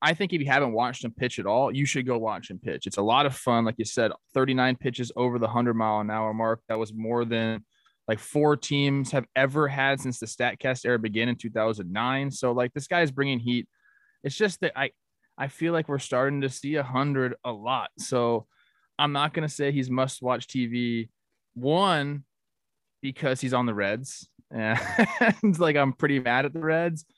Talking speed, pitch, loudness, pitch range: 210 wpm, 130 Hz, -26 LUFS, 120-145 Hz